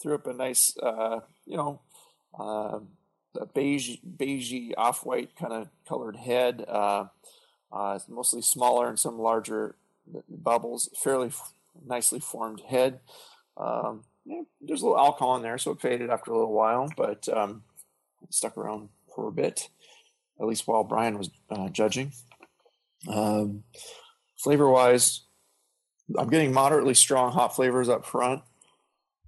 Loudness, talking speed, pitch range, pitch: -26 LUFS, 140 wpm, 105-135 Hz, 120 Hz